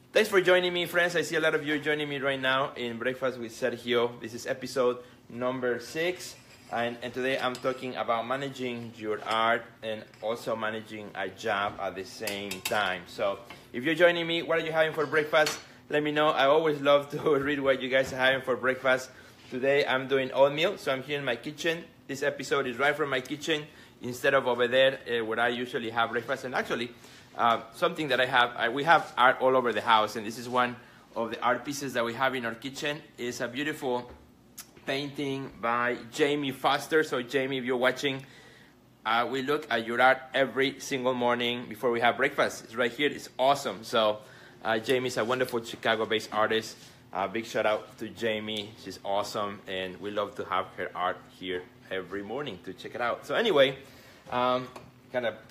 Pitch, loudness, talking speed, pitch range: 125 Hz, -28 LUFS, 205 wpm, 115-140 Hz